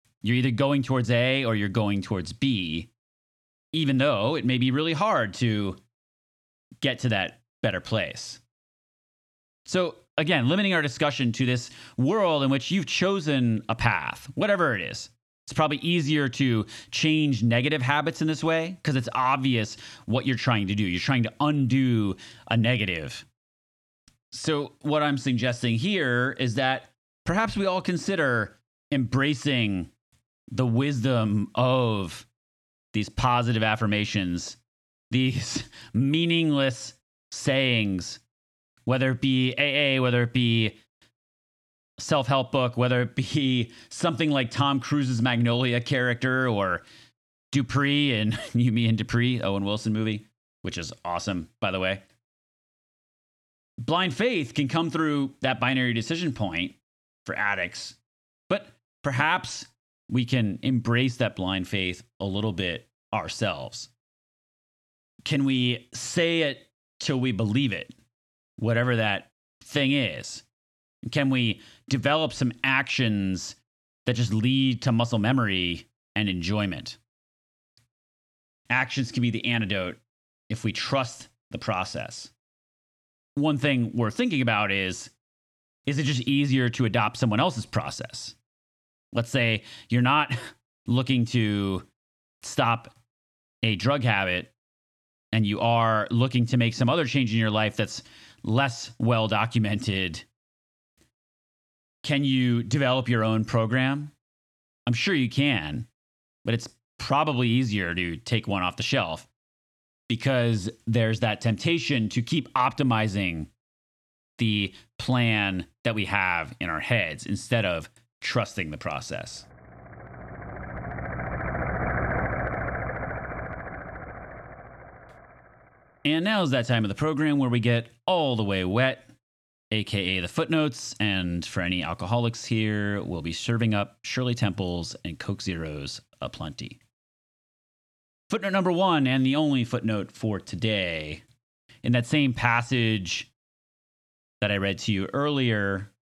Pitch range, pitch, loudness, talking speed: 105-130 Hz, 120 Hz, -26 LUFS, 125 wpm